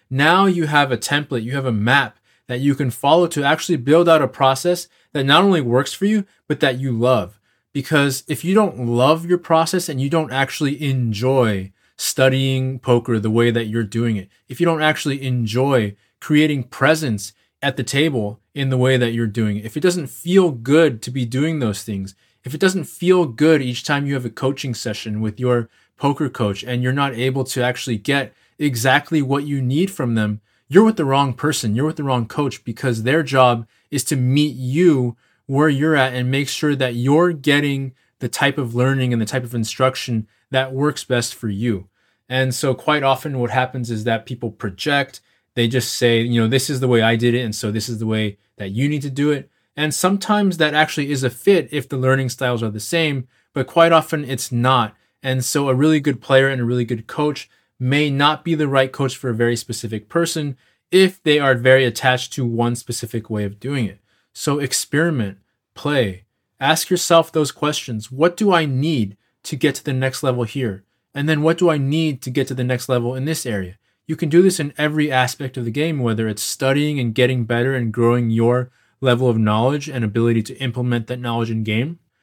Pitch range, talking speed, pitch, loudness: 120-150 Hz, 215 wpm, 130 Hz, -19 LUFS